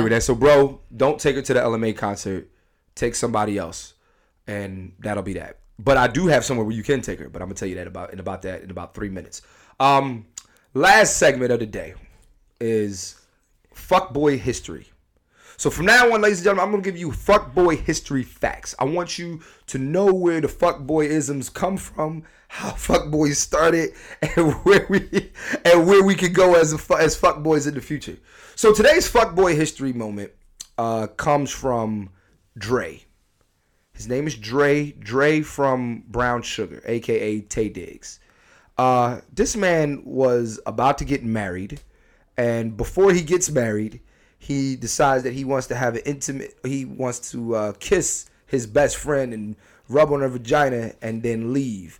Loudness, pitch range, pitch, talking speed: -20 LUFS, 110-155 Hz, 130 Hz, 180 wpm